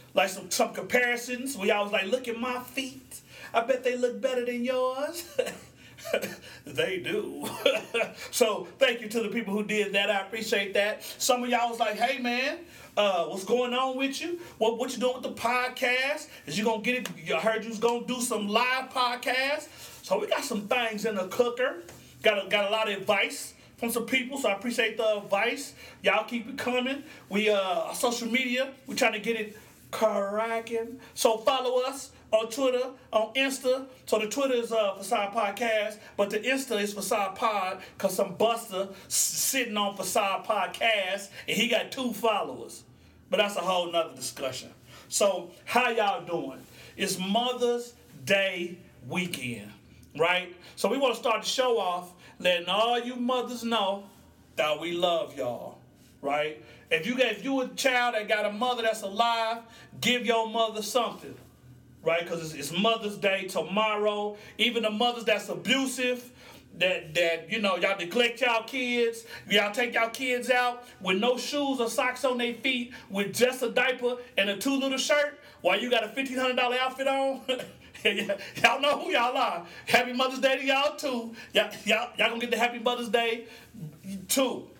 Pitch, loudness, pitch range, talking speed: 230 Hz, -28 LUFS, 200-250 Hz, 180 wpm